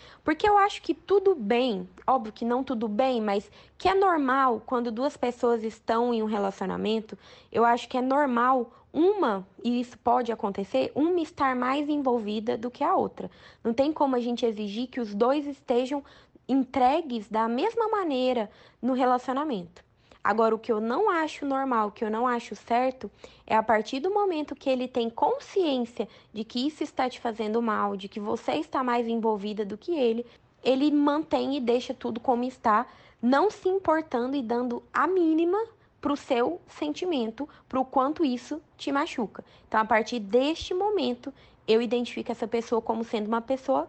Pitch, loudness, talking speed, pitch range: 250 Hz, -27 LUFS, 175 wpm, 230-290 Hz